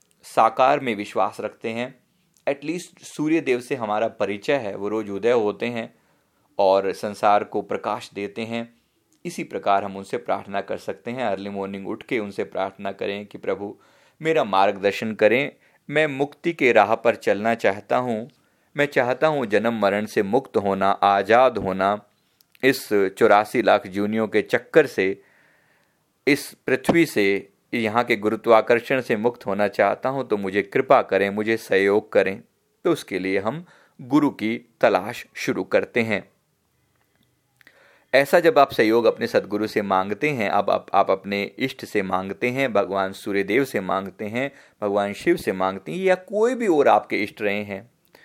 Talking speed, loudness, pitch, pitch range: 165 wpm, -22 LUFS, 110 Hz, 100-130 Hz